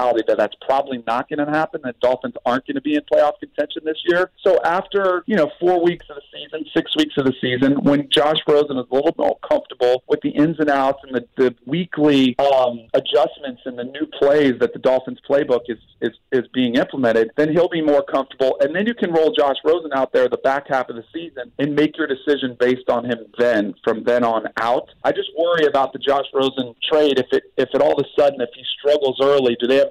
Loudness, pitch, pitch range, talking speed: -19 LUFS, 145 Hz, 130-155 Hz, 235 wpm